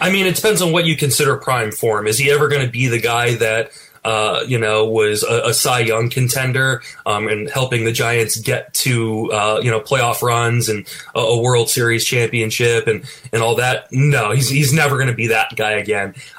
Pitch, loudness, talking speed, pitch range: 120 Hz, -16 LUFS, 220 wpm, 110-135 Hz